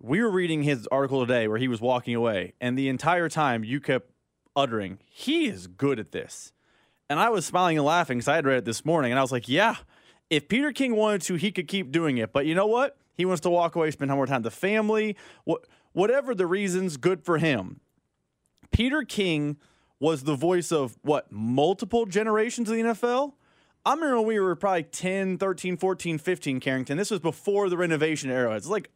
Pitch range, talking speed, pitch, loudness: 135-195 Hz, 220 wpm, 165 Hz, -26 LUFS